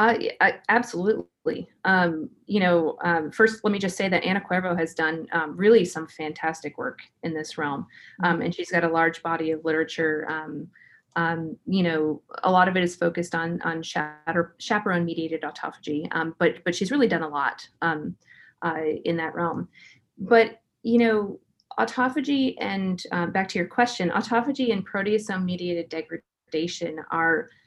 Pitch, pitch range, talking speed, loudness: 170 Hz, 160-200 Hz, 165 wpm, -25 LUFS